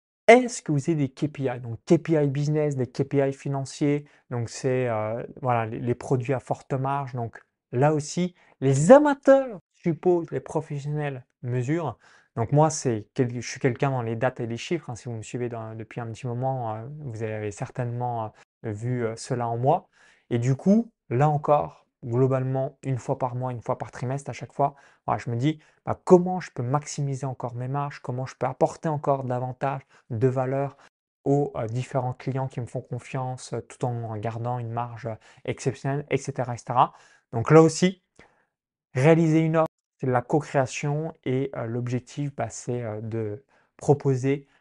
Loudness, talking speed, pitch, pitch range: -26 LUFS, 170 wpm, 135 Hz, 120-150 Hz